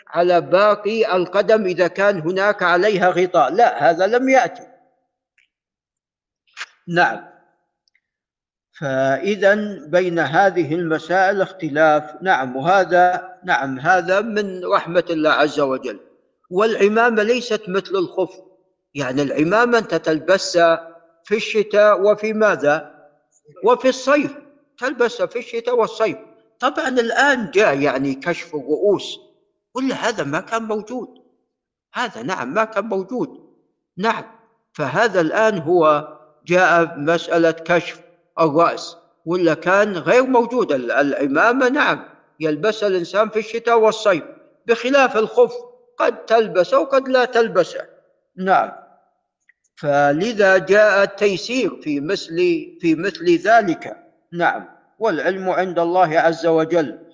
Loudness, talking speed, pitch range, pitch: -18 LUFS, 105 wpm, 170-240 Hz, 200 Hz